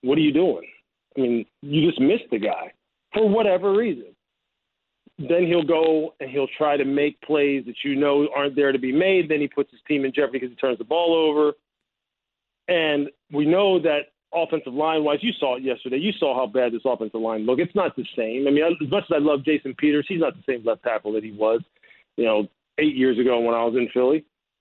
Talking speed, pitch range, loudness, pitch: 230 wpm, 130-165 Hz, -22 LUFS, 145 Hz